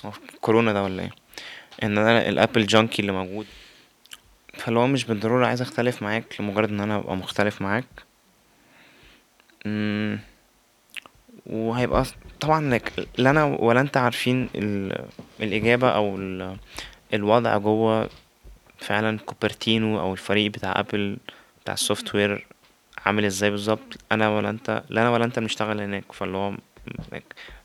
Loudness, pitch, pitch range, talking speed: -24 LUFS, 110 Hz, 100-115 Hz, 125 wpm